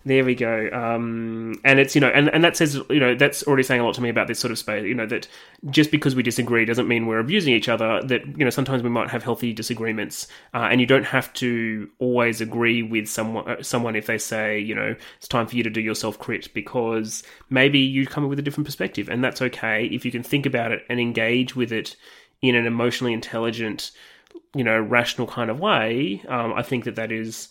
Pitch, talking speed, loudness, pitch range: 120 Hz, 240 wpm, -22 LUFS, 115-130 Hz